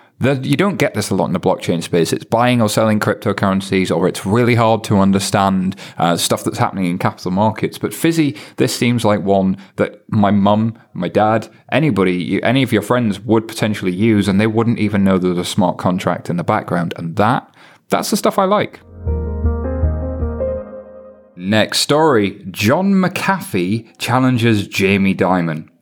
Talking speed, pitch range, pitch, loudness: 170 wpm, 95-115 Hz, 105 Hz, -16 LUFS